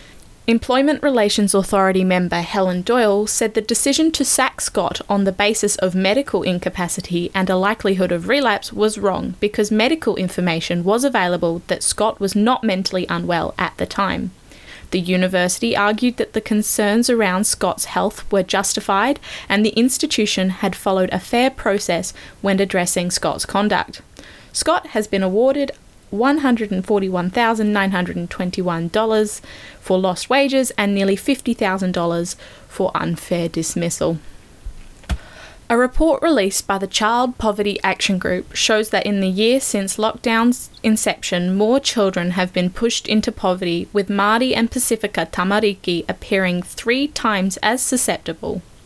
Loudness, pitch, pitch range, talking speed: -18 LUFS, 205 Hz, 185-230 Hz, 135 wpm